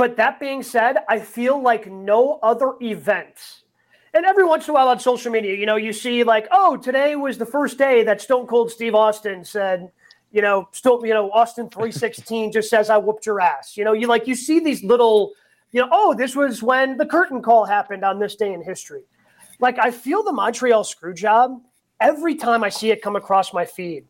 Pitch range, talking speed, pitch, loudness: 210-255 Hz, 220 wpm, 230 Hz, -19 LUFS